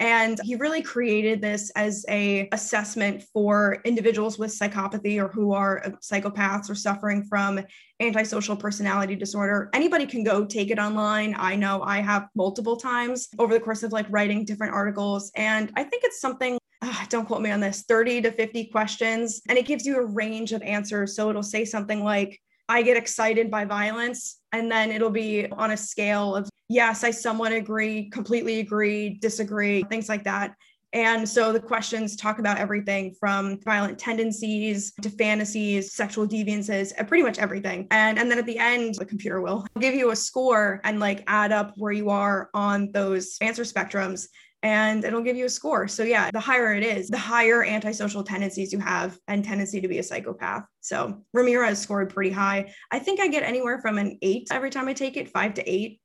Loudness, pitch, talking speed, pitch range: -25 LUFS, 215 Hz, 195 wpm, 205-230 Hz